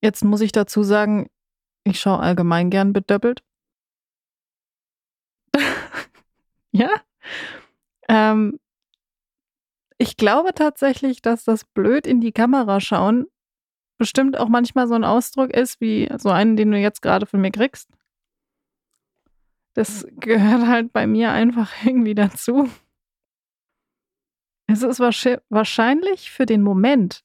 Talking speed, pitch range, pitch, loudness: 115 wpm, 210-250 Hz, 230 Hz, -18 LUFS